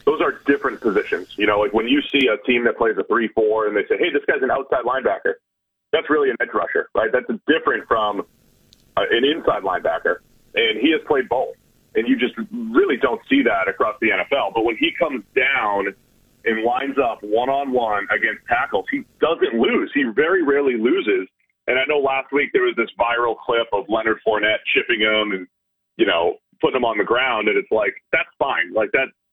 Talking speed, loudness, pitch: 205 wpm, -20 LUFS, 350 Hz